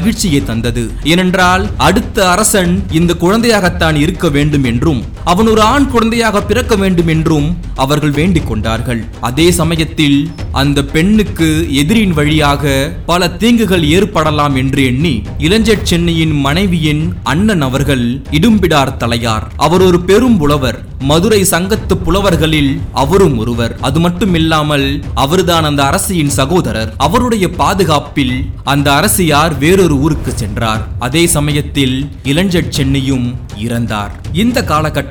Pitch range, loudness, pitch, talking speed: 135-180 Hz, -11 LUFS, 155 Hz, 110 wpm